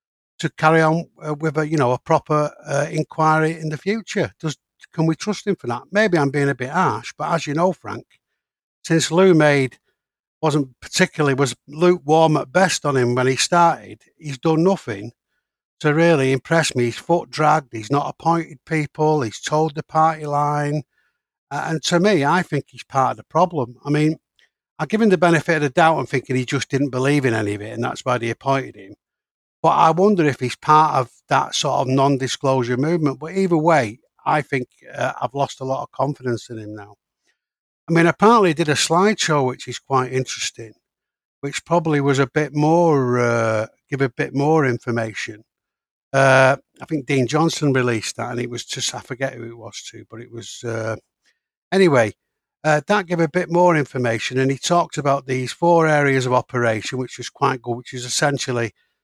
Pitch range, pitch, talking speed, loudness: 125-160 Hz, 145 Hz, 200 wpm, -19 LUFS